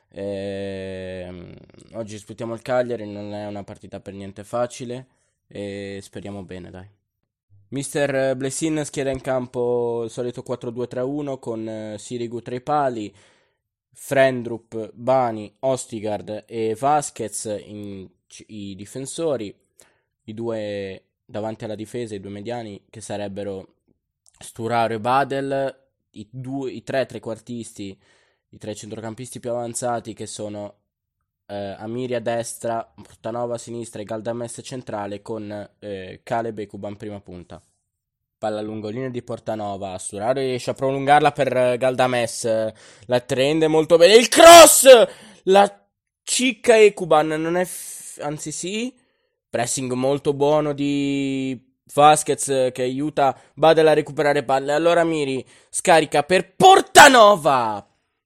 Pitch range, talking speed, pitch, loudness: 105-135 Hz, 125 wpm, 120 Hz, -19 LUFS